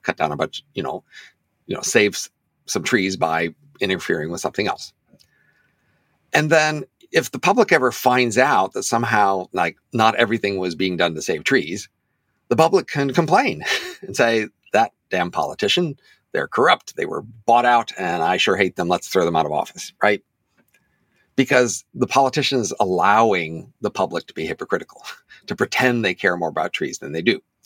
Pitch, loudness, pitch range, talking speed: 120 Hz, -20 LUFS, 100-145 Hz, 180 wpm